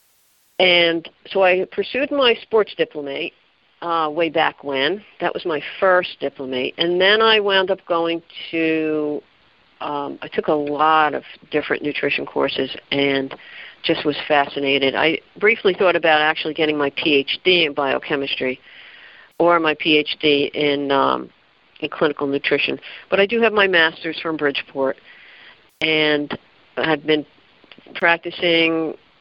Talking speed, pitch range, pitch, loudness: 135 wpm, 145-175 Hz, 155 Hz, -19 LUFS